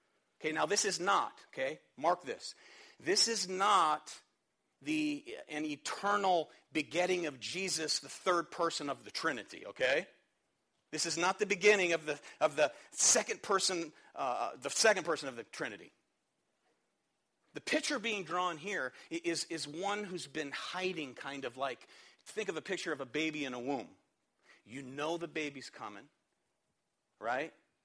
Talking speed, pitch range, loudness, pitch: 155 wpm, 155-205 Hz, -34 LUFS, 175 Hz